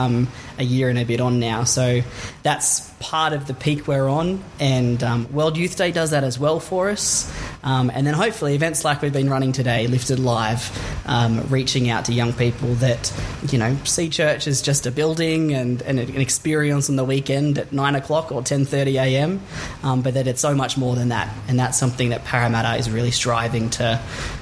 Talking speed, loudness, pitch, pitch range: 210 wpm, -20 LUFS, 130 Hz, 120-145 Hz